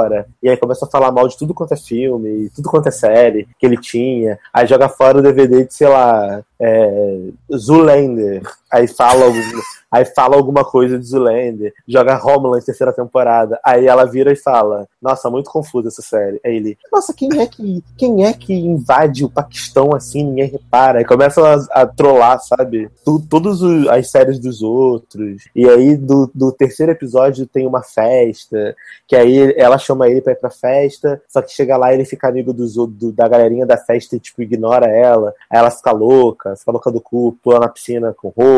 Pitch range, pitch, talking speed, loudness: 115-140 Hz, 130 Hz, 200 wpm, -12 LUFS